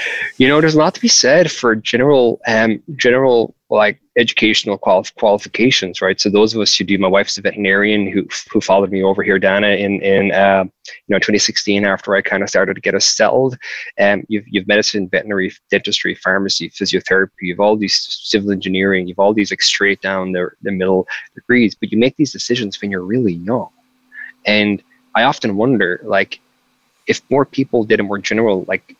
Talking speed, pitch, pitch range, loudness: 190 wpm, 100 Hz, 95-120 Hz, -15 LUFS